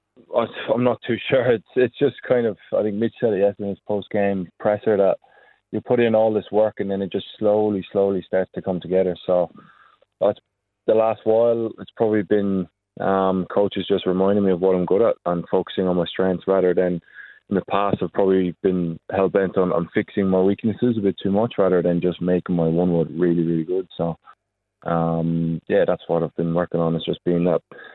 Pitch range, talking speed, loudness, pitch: 90-105 Hz, 215 wpm, -21 LUFS, 95 Hz